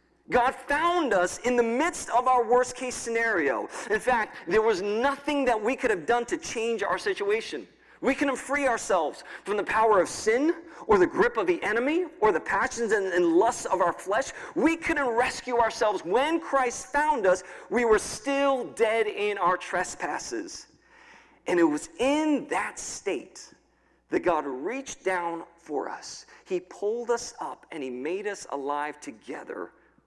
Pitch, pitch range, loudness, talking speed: 270 Hz, 230-350 Hz, -26 LUFS, 170 wpm